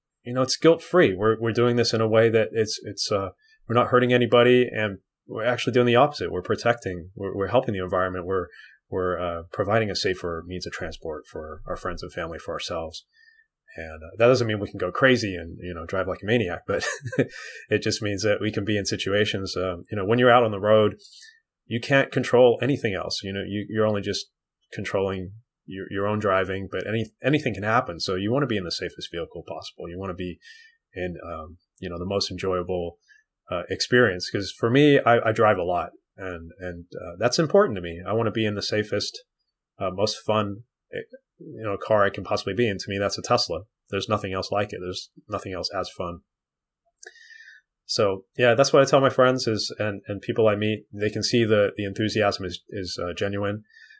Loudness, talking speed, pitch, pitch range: -24 LUFS, 220 wpm, 105 Hz, 95-120 Hz